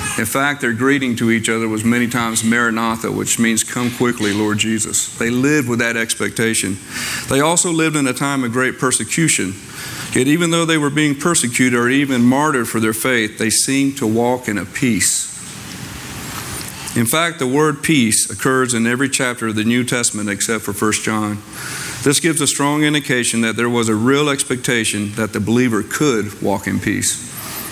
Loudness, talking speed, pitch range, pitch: -16 LUFS, 185 wpm, 110-135 Hz, 120 Hz